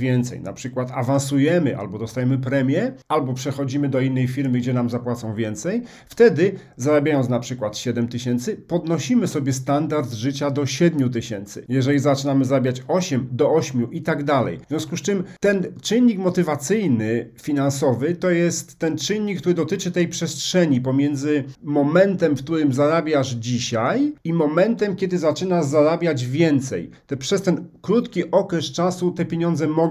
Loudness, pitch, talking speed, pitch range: -21 LUFS, 150 Hz, 150 wpm, 130-175 Hz